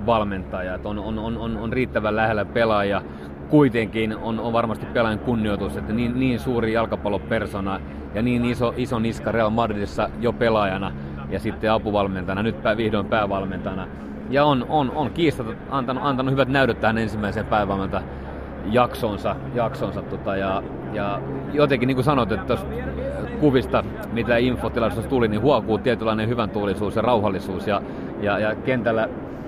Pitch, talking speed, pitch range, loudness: 110 Hz, 145 wpm, 100-120 Hz, -23 LUFS